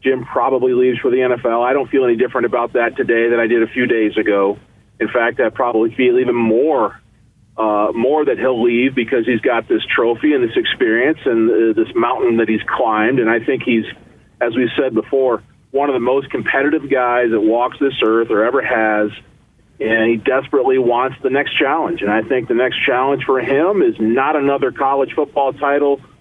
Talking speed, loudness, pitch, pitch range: 205 wpm, -16 LUFS, 125 Hz, 115-145 Hz